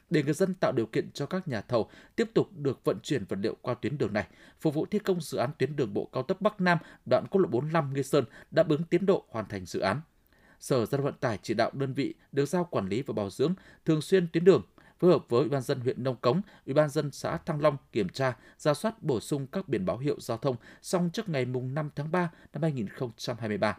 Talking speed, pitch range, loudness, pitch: 255 wpm, 135-180 Hz, -30 LUFS, 155 Hz